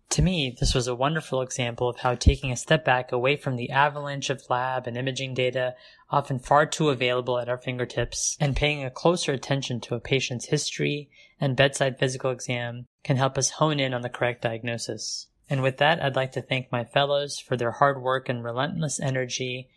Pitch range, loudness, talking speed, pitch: 125-140 Hz, -26 LUFS, 205 wpm, 130 Hz